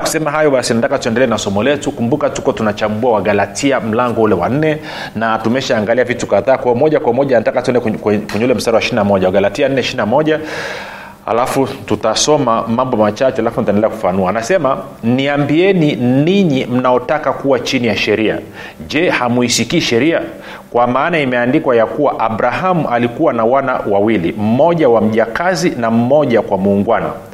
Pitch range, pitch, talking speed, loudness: 110-145 Hz, 125 Hz, 135 wpm, -14 LUFS